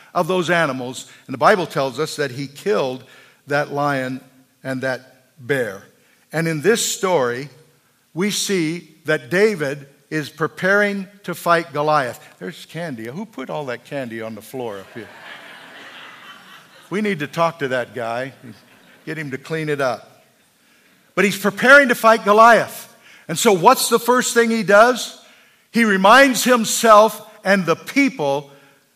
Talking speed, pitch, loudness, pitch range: 155 wpm, 160 Hz, -17 LUFS, 135-205 Hz